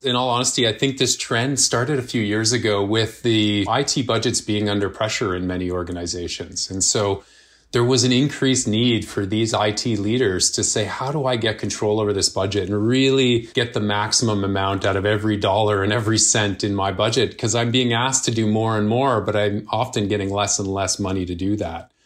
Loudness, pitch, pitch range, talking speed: -20 LUFS, 110 Hz, 100-120 Hz, 215 wpm